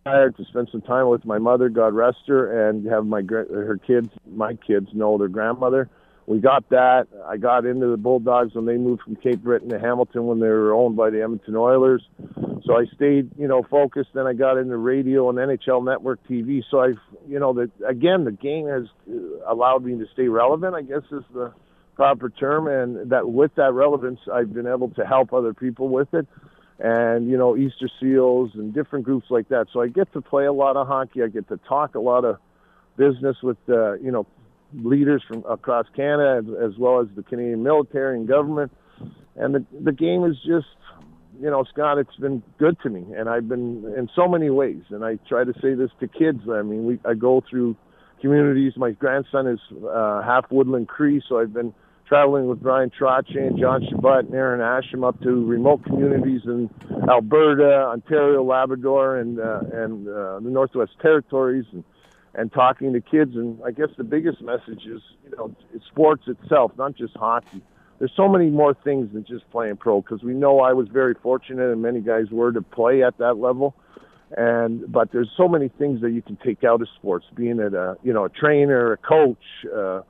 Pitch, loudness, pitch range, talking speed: 125 Hz, -21 LUFS, 115-135 Hz, 205 wpm